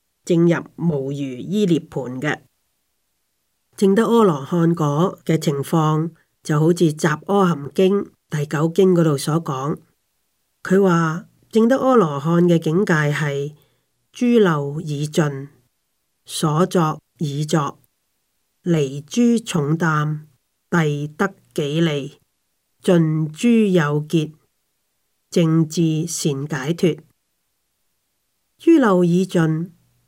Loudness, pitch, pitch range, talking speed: -19 LUFS, 160 Hz, 150-180 Hz, 140 characters per minute